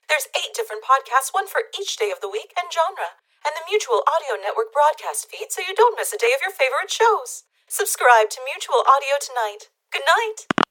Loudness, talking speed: -21 LUFS, 205 wpm